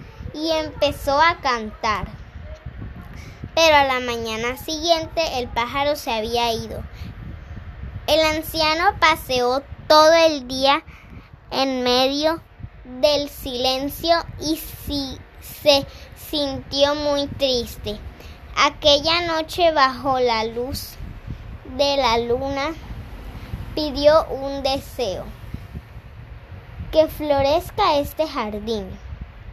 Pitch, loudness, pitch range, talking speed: 280 Hz, -20 LUFS, 250-310 Hz, 90 wpm